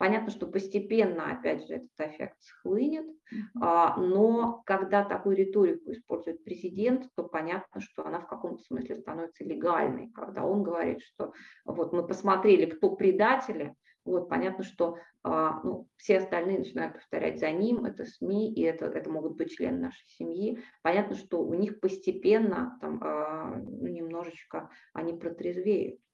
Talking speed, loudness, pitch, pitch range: 145 wpm, -30 LUFS, 190 Hz, 170-220 Hz